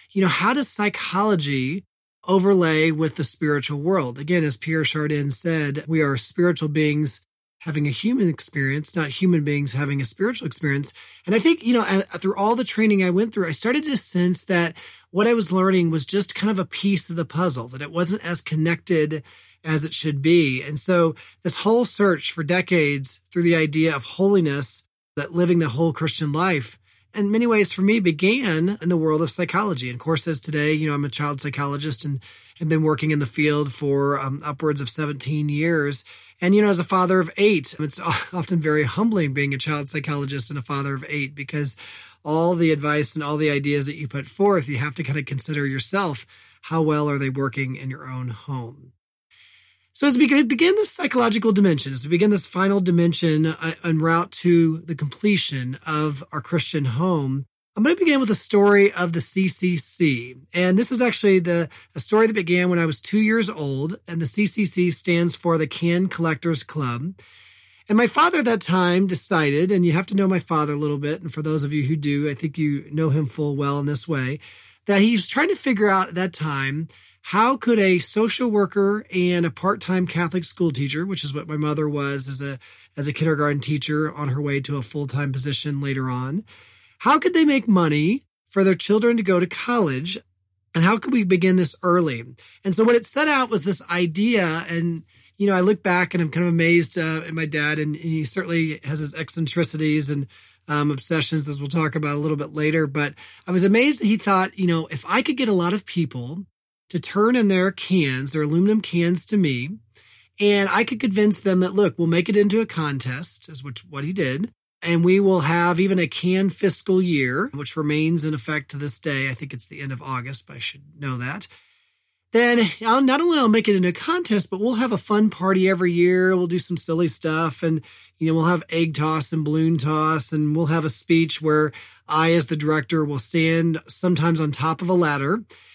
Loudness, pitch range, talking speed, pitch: -21 LUFS, 145-190 Hz, 215 wpm, 165 Hz